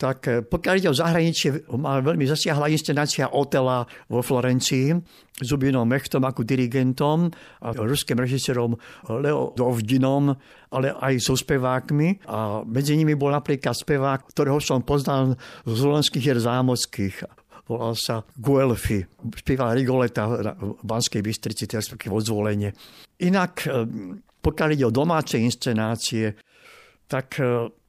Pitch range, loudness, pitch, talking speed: 115-145 Hz, -23 LUFS, 130 Hz, 120 wpm